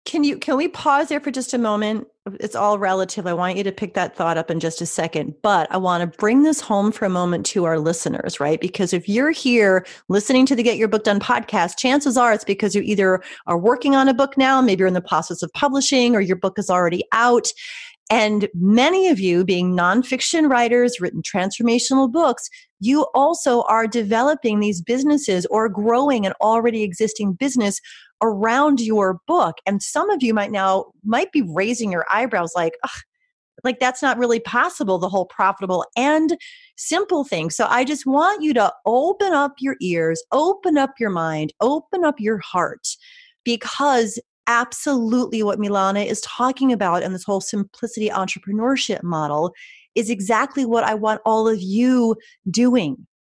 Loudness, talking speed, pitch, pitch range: -19 LUFS, 185 wpm, 225 Hz, 190-265 Hz